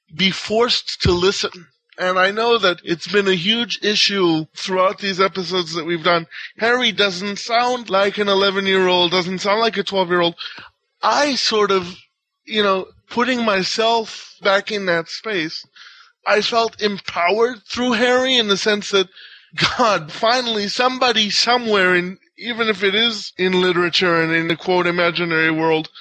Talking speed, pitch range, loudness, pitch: 165 wpm, 180-230 Hz, -17 LUFS, 195 Hz